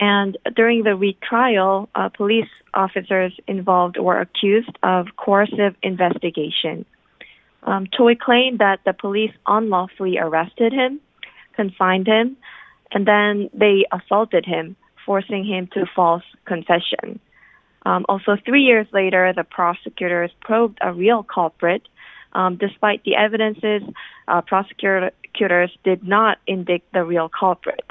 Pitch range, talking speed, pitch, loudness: 185-215 Hz, 125 wpm, 200 Hz, -19 LUFS